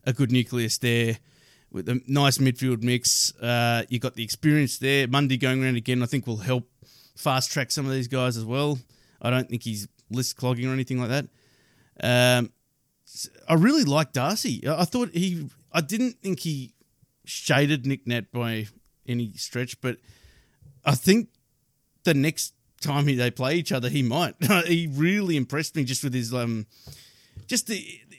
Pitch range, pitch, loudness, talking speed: 120-145 Hz, 130 Hz, -25 LUFS, 170 wpm